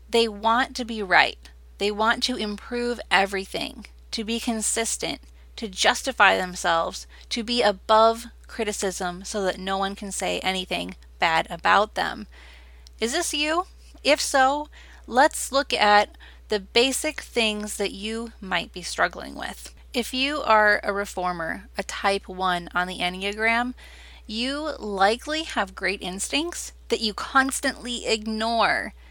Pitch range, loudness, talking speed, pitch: 190-240 Hz, -24 LUFS, 140 wpm, 215 Hz